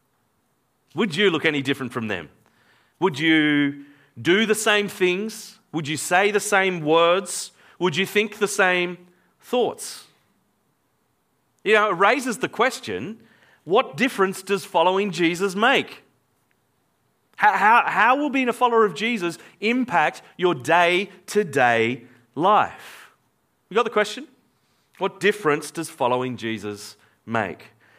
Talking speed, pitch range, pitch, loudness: 135 wpm, 145-205 Hz, 180 Hz, -21 LUFS